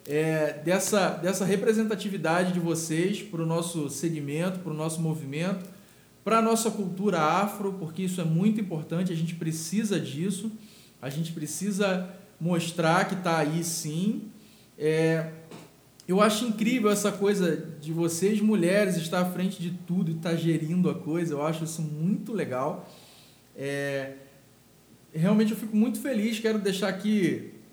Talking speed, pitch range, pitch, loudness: 150 wpm, 160-205 Hz, 180 Hz, -27 LUFS